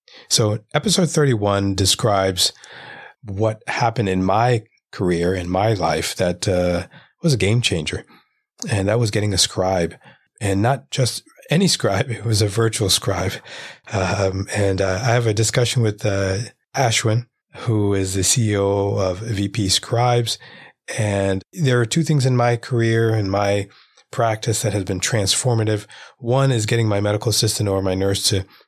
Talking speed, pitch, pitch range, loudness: 160 wpm, 105 Hz, 95-120 Hz, -19 LUFS